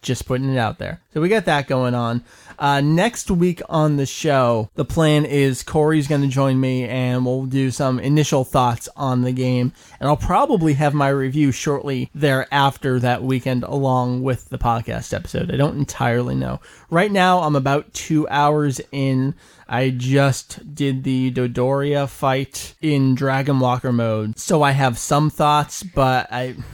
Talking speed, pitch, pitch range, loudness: 175 wpm, 135 Hz, 125-145 Hz, -19 LUFS